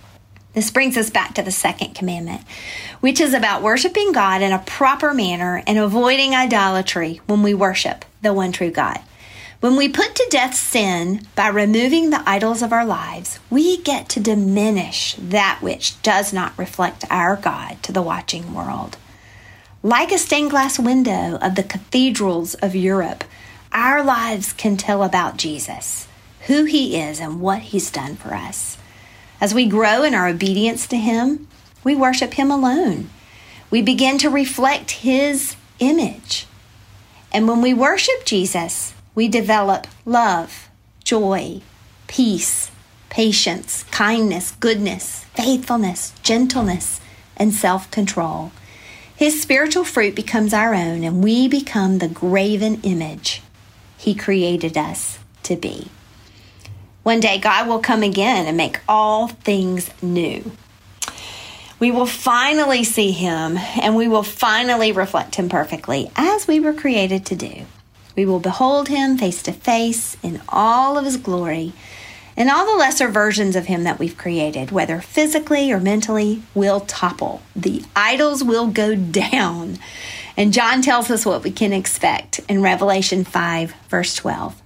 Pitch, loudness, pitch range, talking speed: 210 Hz, -18 LUFS, 180-250 Hz, 145 wpm